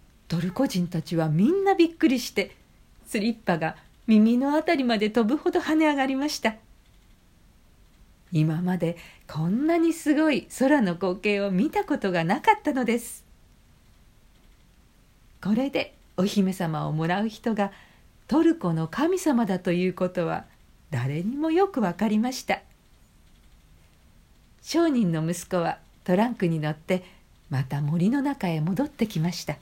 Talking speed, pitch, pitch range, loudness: 265 characters per minute, 195 Hz, 165-265 Hz, -25 LUFS